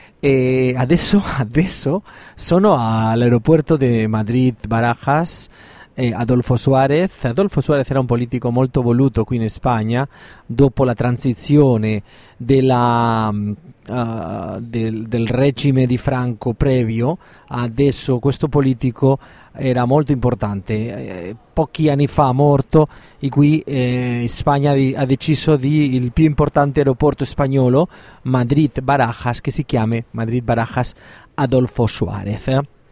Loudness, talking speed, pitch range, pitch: -17 LUFS, 120 wpm, 120-140 Hz, 130 Hz